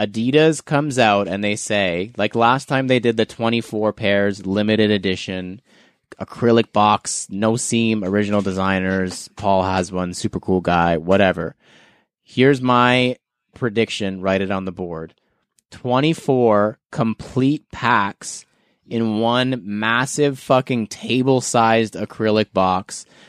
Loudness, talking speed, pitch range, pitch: -19 LUFS, 125 wpm, 95-125 Hz, 110 Hz